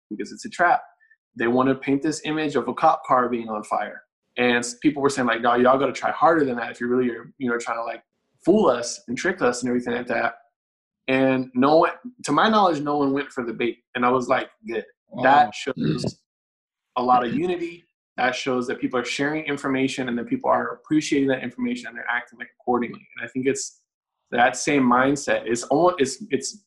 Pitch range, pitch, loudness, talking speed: 125-145 Hz, 130 Hz, -22 LUFS, 230 wpm